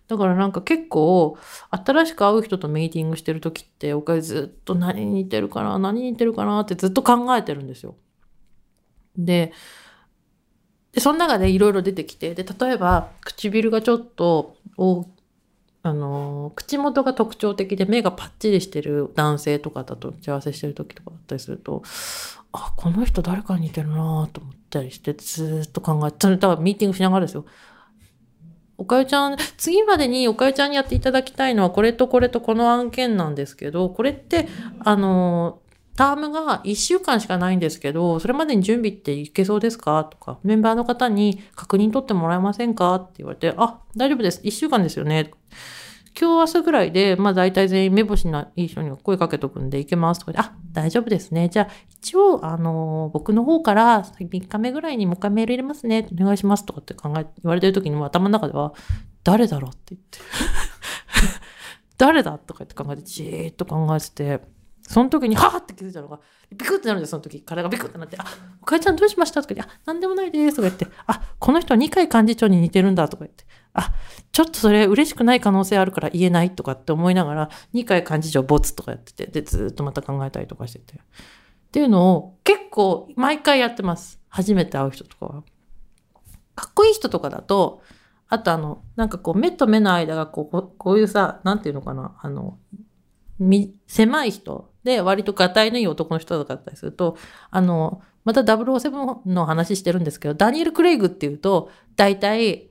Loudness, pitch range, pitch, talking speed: -20 LUFS, 160-230 Hz, 190 Hz, 395 characters per minute